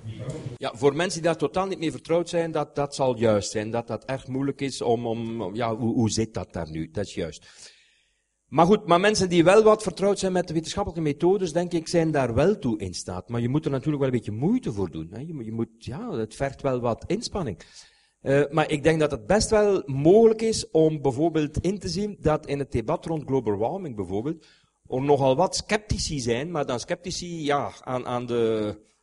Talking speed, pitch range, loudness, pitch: 225 wpm, 115-170 Hz, -25 LUFS, 145 Hz